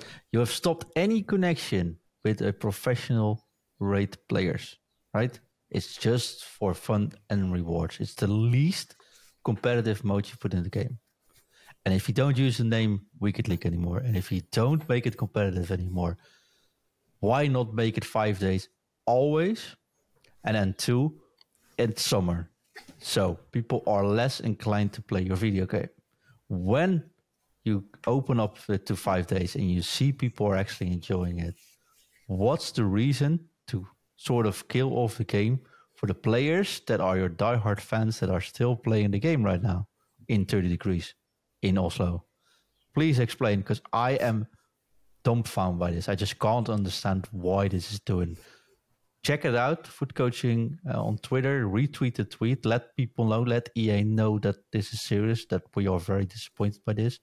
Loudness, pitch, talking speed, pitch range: -28 LUFS, 110 Hz, 165 wpm, 100-125 Hz